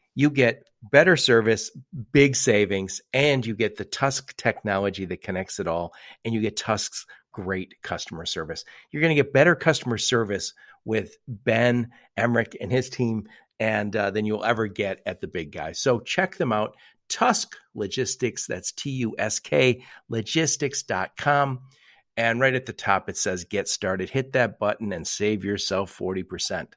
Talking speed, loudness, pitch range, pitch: 165 wpm, -24 LUFS, 105-135 Hz, 115 Hz